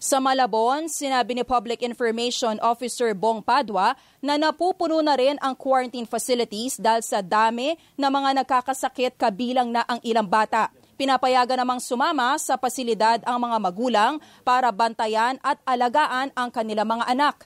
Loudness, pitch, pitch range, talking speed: -23 LUFS, 250 Hz, 230-265 Hz, 150 wpm